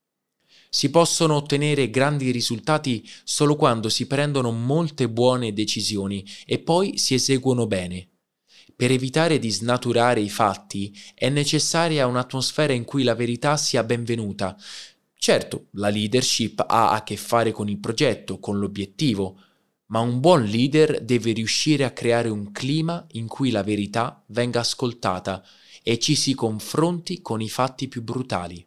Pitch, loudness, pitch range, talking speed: 120 Hz, -22 LUFS, 110-140 Hz, 145 wpm